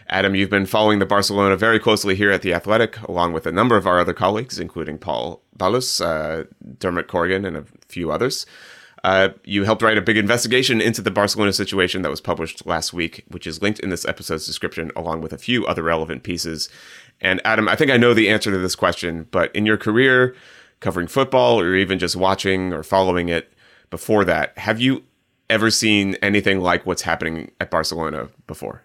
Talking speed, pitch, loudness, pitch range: 200 wpm, 95 Hz, -19 LUFS, 85-110 Hz